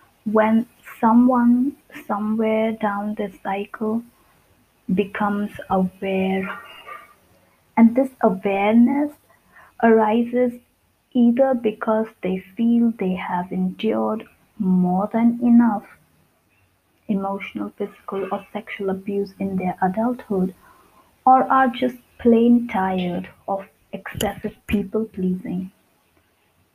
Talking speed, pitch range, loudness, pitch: 90 wpm, 190-235 Hz, -21 LUFS, 210 Hz